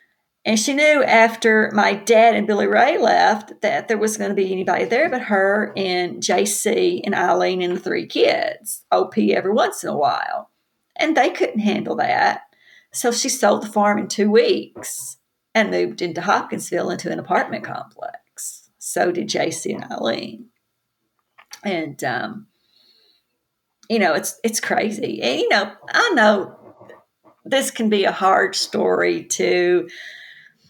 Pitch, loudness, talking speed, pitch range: 210 Hz, -19 LUFS, 155 wpm, 180-230 Hz